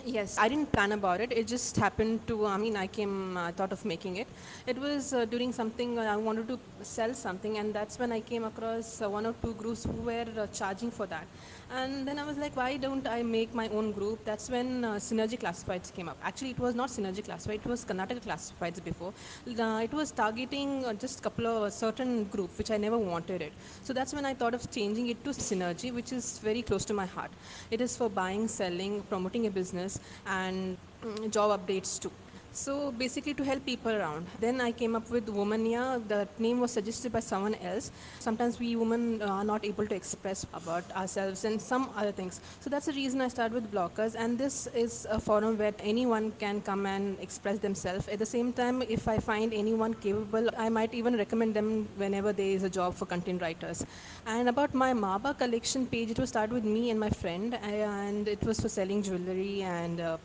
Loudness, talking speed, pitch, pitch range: -33 LUFS, 220 wpm, 220 Hz, 200-240 Hz